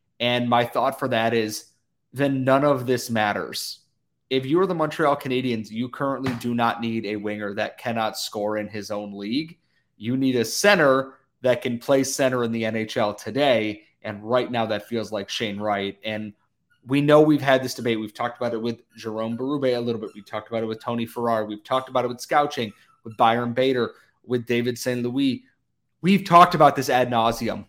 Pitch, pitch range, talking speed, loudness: 120 Hz, 110-135 Hz, 205 wpm, -23 LUFS